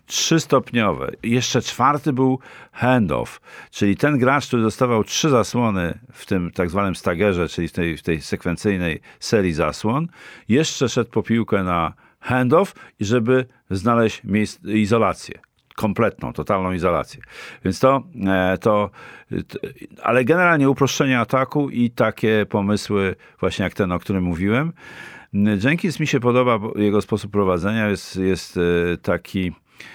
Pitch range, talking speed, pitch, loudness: 95-125 Hz, 130 wpm, 105 Hz, -20 LUFS